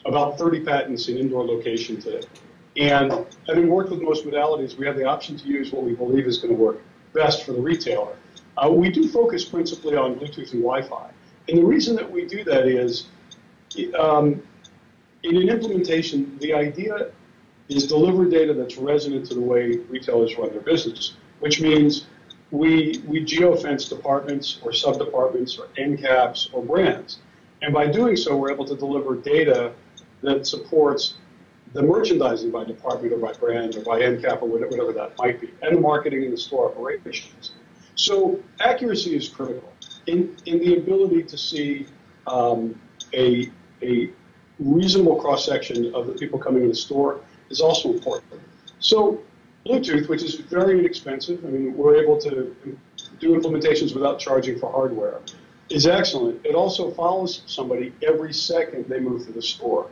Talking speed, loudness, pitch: 165 wpm, -22 LUFS, 155 Hz